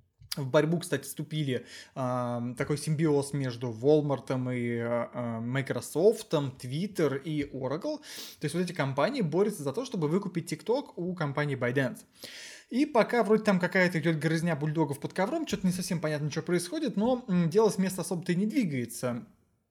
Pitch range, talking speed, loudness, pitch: 135-190 Hz, 160 wpm, -30 LUFS, 155 Hz